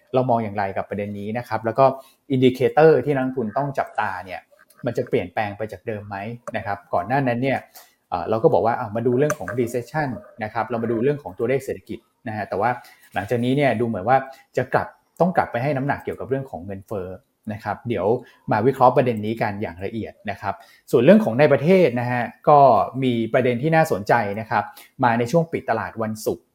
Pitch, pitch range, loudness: 120 Hz, 110-135 Hz, -21 LUFS